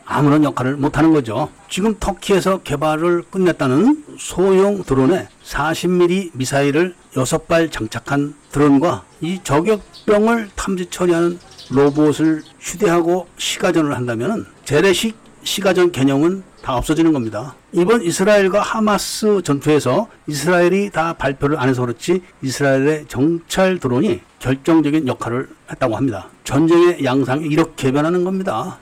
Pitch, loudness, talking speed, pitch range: 160 Hz, -17 LUFS, 315 characters per minute, 140-185 Hz